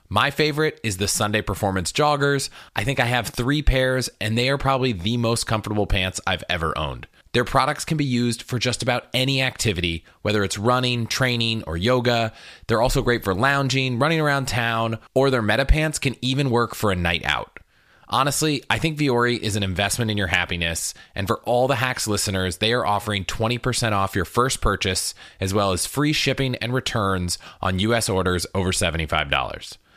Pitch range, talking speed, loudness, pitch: 100-130 Hz, 190 wpm, -22 LUFS, 115 Hz